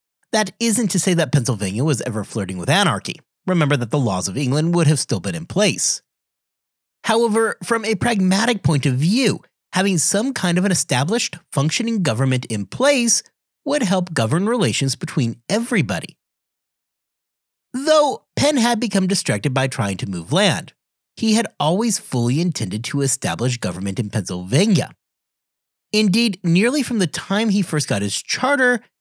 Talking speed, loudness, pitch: 155 wpm, -19 LUFS, 170 Hz